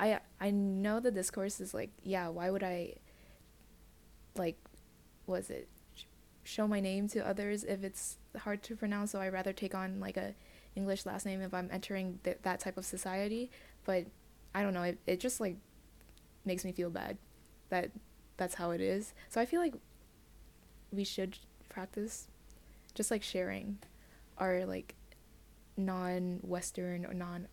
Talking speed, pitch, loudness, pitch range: 165 wpm, 190 Hz, -38 LUFS, 180-205 Hz